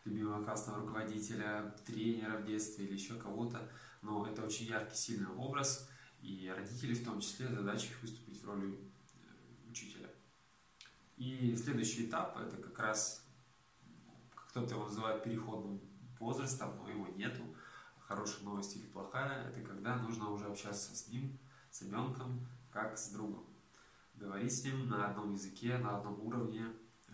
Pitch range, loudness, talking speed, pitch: 105-120 Hz, -42 LUFS, 145 wpm, 110 Hz